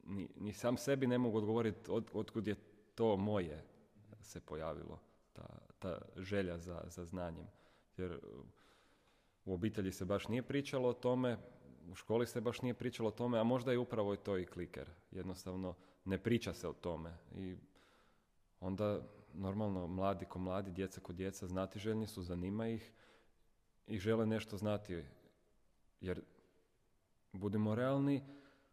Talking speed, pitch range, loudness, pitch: 150 wpm, 90-115 Hz, -41 LUFS, 100 Hz